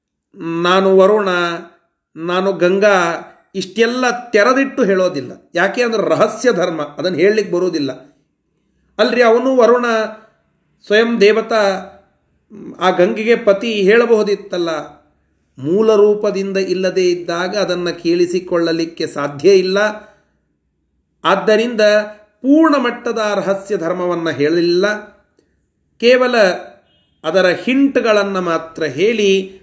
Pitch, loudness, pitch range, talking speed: 195 Hz, -15 LUFS, 175-215 Hz, 85 wpm